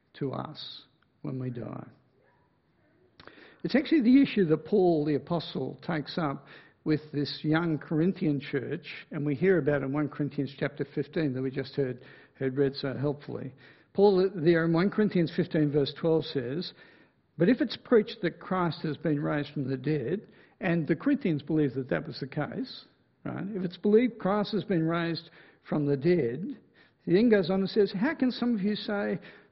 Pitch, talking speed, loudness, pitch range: 160 Hz, 185 wpm, -29 LUFS, 145-195 Hz